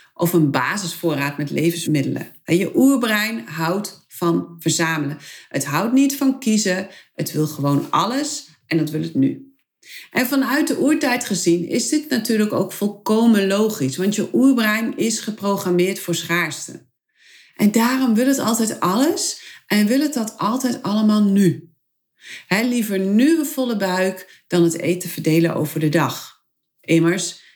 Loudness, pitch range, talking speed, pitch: -19 LUFS, 170-250 Hz, 150 wpm, 200 Hz